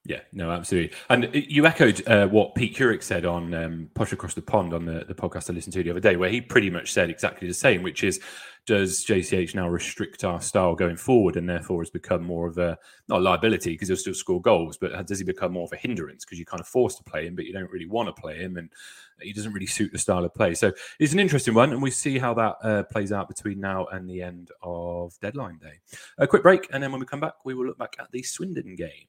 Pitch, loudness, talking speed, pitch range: 95 Hz, -25 LUFS, 270 wpm, 85-120 Hz